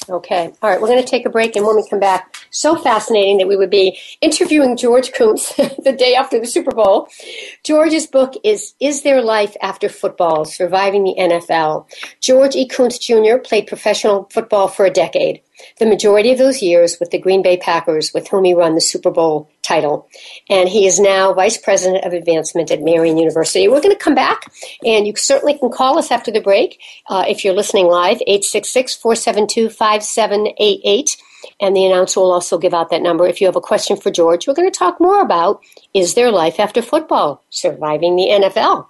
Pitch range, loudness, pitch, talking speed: 185-255 Hz, -14 LUFS, 205 Hz, 200 wpm